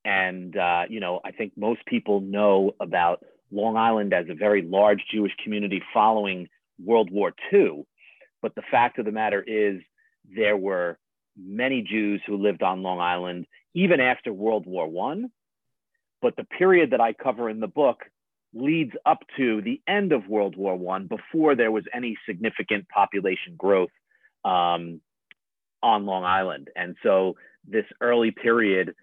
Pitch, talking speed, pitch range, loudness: 105 Hz, 160 wpm, 95-115 Hz, -24 LUFS